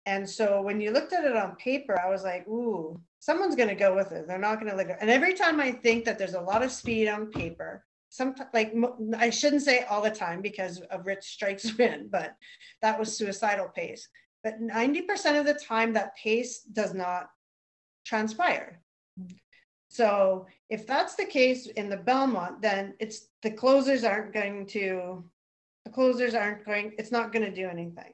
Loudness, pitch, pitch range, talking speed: -28 LUFS, 220 Hz, 195-250 Hz, 195 wpm